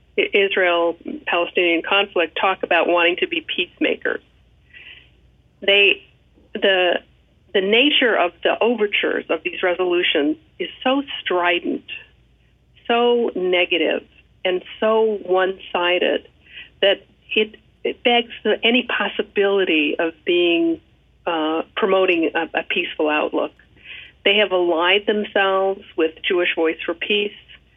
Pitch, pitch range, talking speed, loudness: 195 Hz, 175-235 Hz, 105 wpm, -19 LUFS